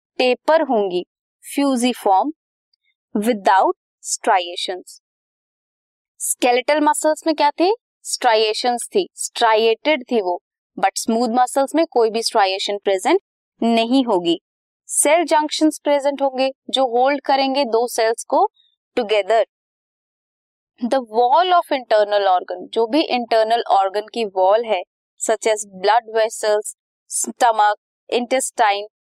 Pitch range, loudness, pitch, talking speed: 215-290 Hz, -18 LUFS, 245 Hz, 110 wpm